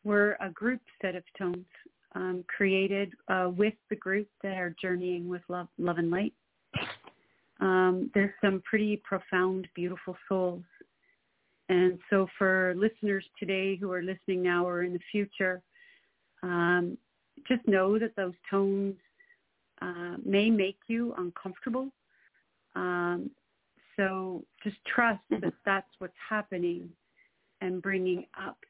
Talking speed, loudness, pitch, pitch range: 130 wpm, -31 LUFS, 190 Hz, 180-205 Hz